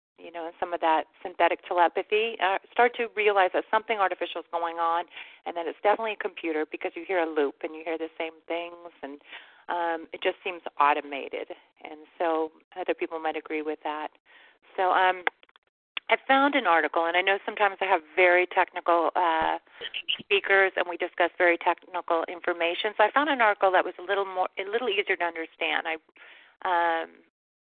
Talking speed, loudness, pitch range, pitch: 190 wpm, -26 LUFS, 165-195 Hz, 175 Hz